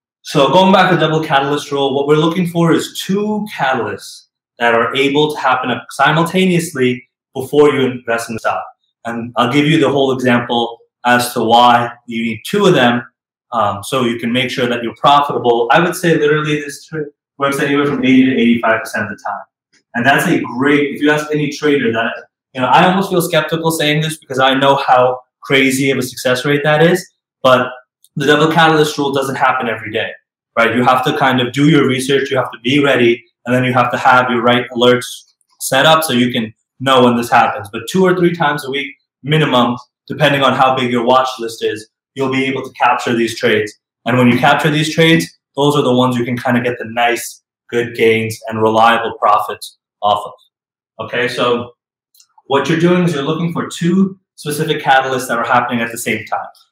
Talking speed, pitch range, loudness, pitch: 215 wpm, 120-150 Hz, -14 LUFS, 130 Hz